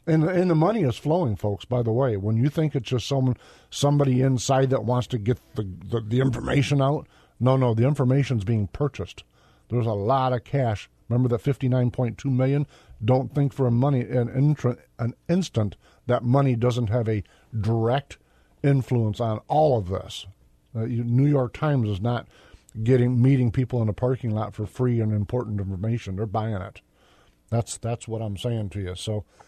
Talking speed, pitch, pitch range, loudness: 190 wpm, 120 Hz, 110-130 Hz, -24 LUFS